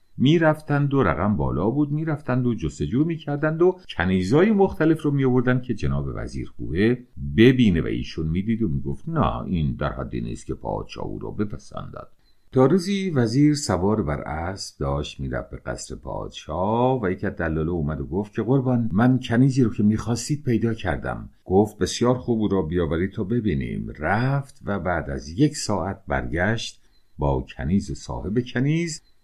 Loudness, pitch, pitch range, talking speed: -23 LUFS, 110 Hz, 85-130 Hz, 170 wpm